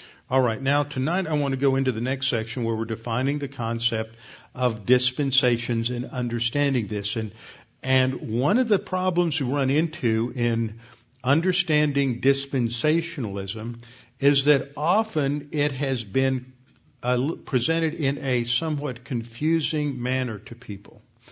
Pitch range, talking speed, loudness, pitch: 120-145 Hz, 140 wpm, -24 LUFS, 130 Hz